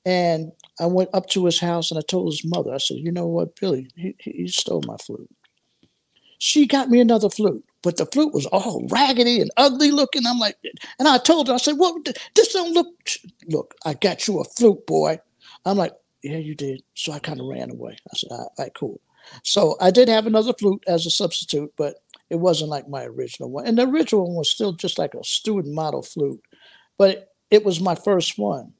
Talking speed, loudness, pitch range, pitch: 225 wpm, -20 LUFS, 165-250 Hz, 190 Hz